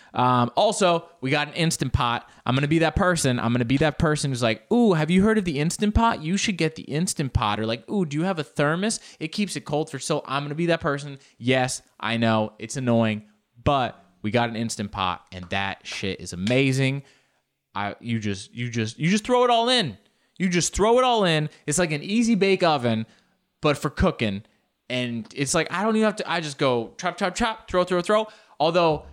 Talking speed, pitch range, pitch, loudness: 230 wpm, 120-180 Hz, 145 Hz, -23 LUFS